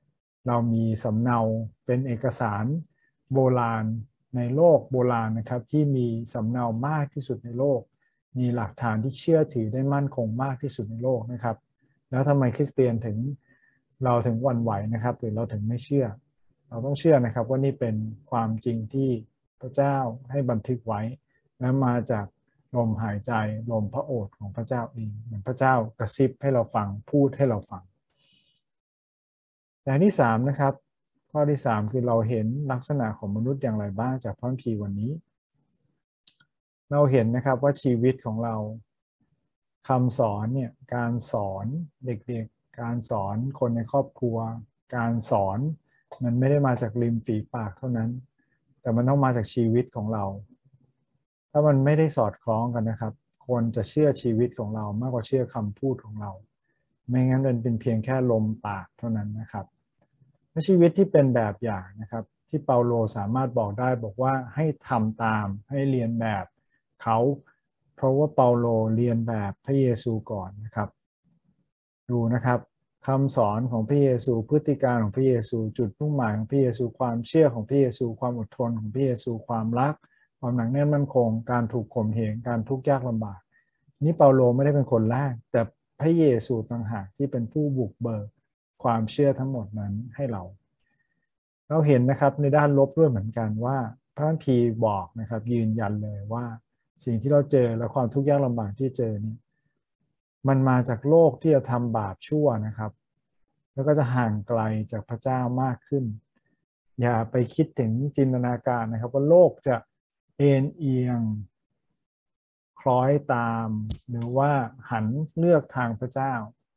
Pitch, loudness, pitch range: 120 Hz, -25 LUFS, 115-135 Hz